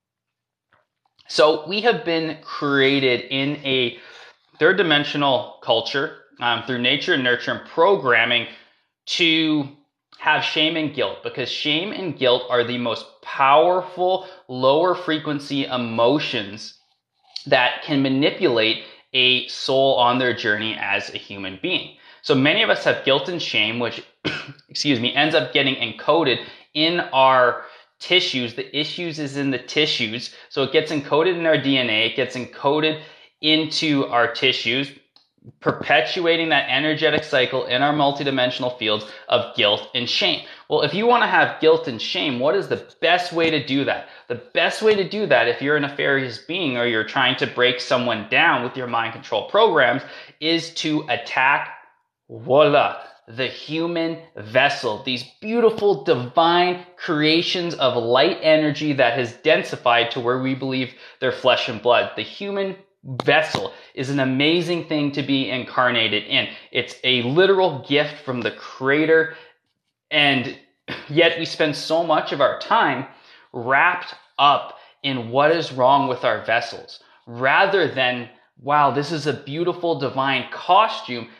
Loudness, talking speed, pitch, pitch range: -20 LUFS, 150 wpm, 140 Hz, 125-160 Hz